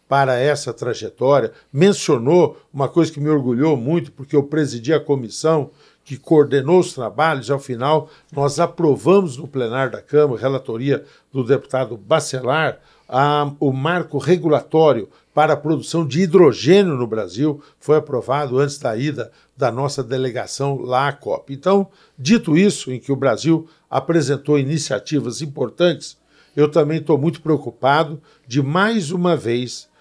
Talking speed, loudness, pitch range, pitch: 145 wpm, -18 LUFS, 135-160 Hz, 145 Hz